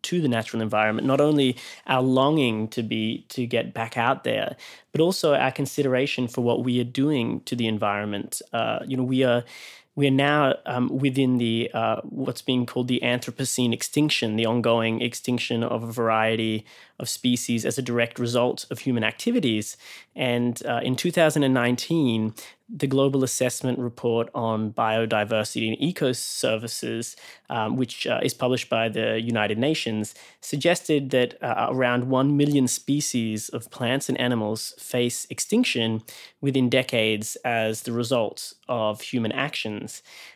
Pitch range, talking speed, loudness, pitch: 115-130 Hz, 155 wpm, -24 LUFS, 125 Hz